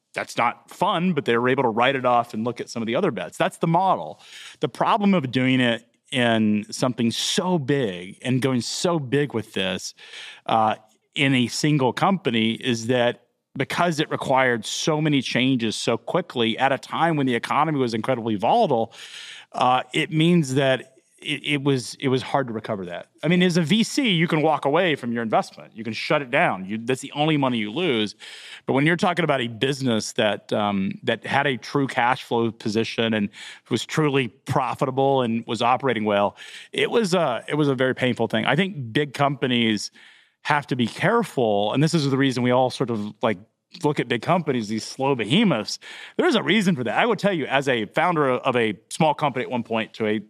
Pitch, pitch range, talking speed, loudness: 130 Hz, 115-150 Hz, 210 wpm, -22 LUFS